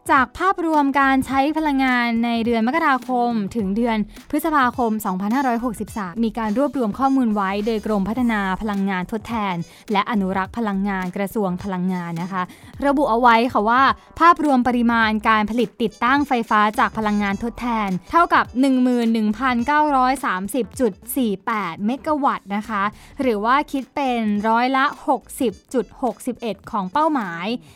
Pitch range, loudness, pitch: 210-265 Hz, -20 LUFS, 235 Hz